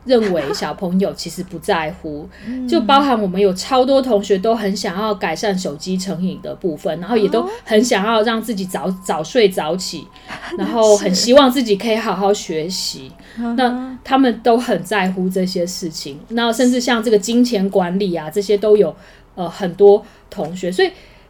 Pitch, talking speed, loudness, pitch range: 205 Hz, 265 characters per minute, -17 LUFS, 185-230 Hz